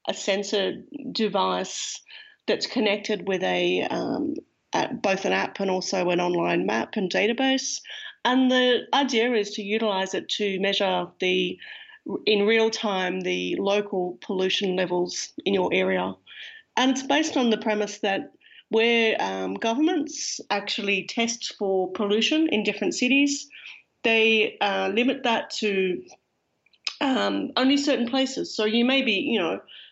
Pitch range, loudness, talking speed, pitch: 195-265 Hz, -24 LUFS, 140 wpm, 220 Hz